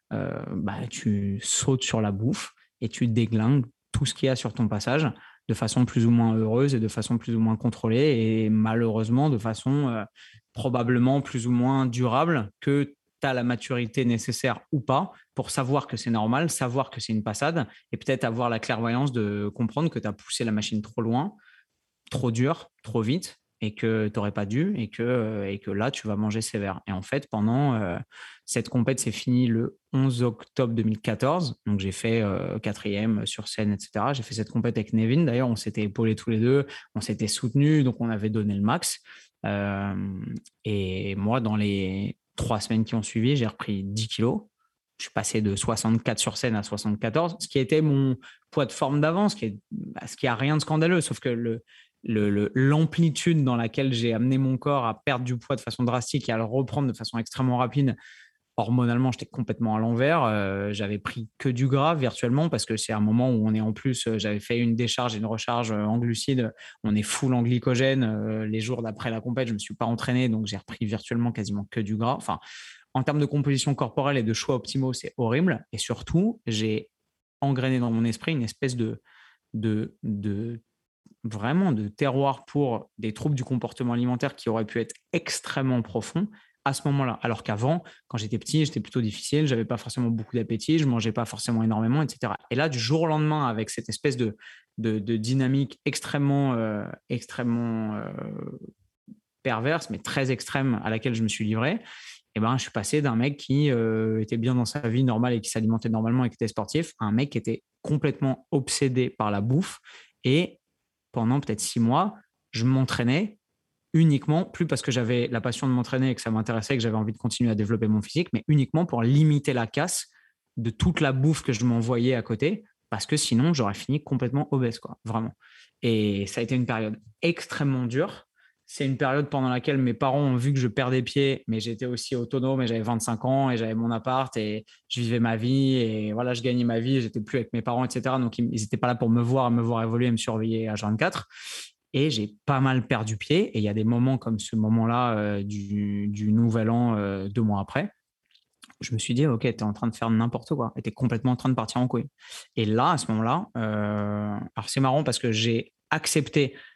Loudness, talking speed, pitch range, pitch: -26 LUFS, 215 wpm, 110-135 Hz, 120 Hz